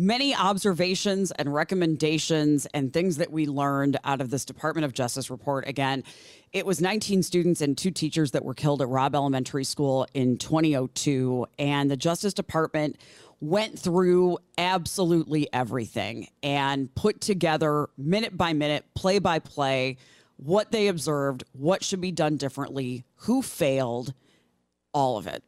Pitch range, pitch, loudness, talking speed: 135-180 Hz, 150 Hz, -26 LUFS, 150 wpm